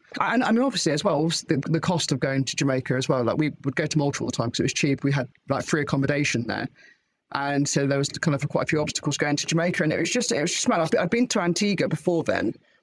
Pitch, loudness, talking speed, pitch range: 150 Hz, -24 LUFS, 285 wpm, 140-170 Hz